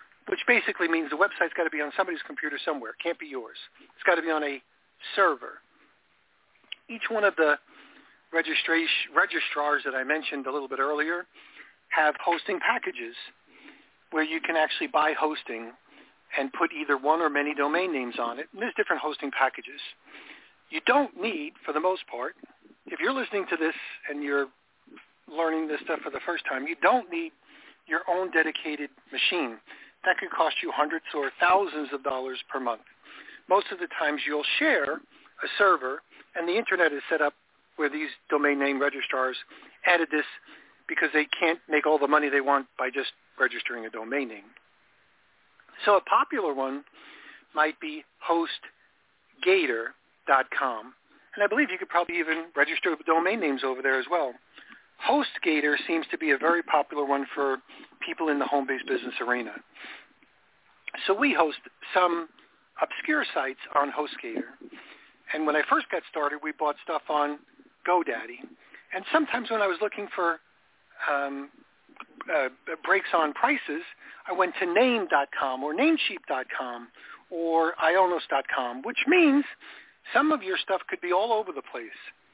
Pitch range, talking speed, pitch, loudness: 145-200 Hz, 160 wpm, 160 Hz, -27 LUFS